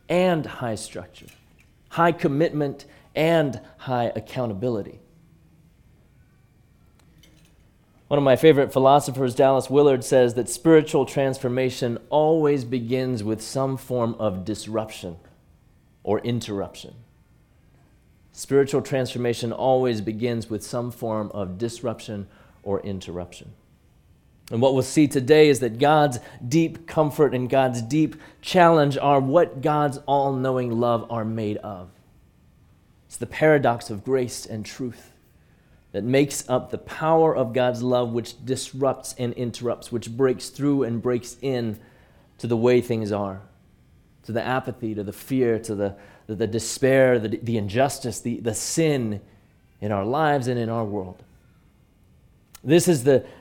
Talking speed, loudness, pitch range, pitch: 135 wpm, -23 LUFS, 110-140 Hz, 125 Hz